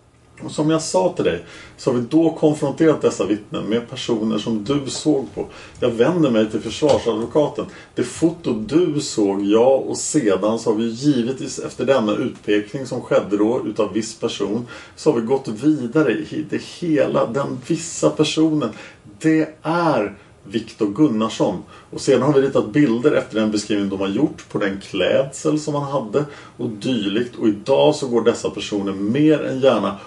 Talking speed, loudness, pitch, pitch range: 175 wpm, -20 LUFS, 135 Hz, 110-155 Hz